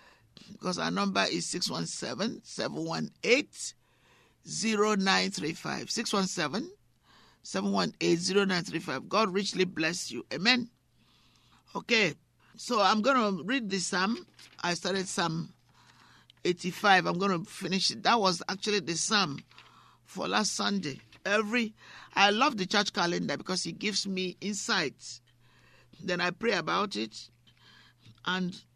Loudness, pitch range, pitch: -29 LUFS, 170-205 Hz, 190 Hz